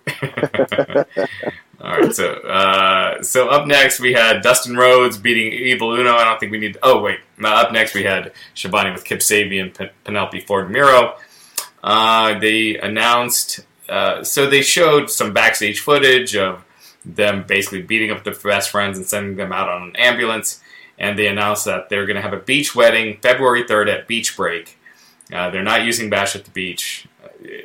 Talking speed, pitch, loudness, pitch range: 180 wpm, 110 Hz, -15 LUFS, 100-125 Hz